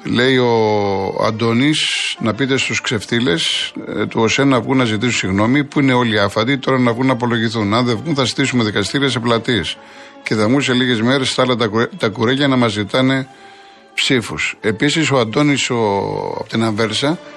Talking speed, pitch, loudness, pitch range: 180 wpm, 125 Hz, -16 LUFS, 115-135 Hz